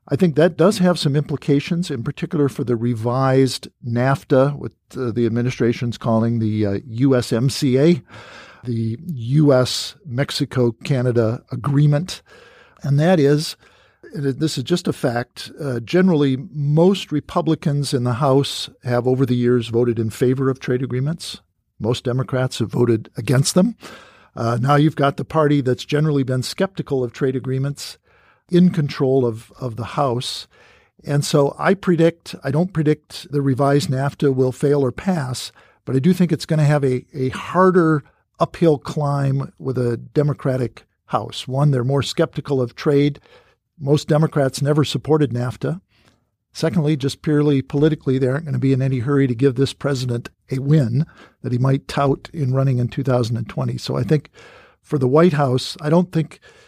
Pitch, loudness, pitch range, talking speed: 140 Hz, -19 LUFS, 125-150 Hz, 165 wpm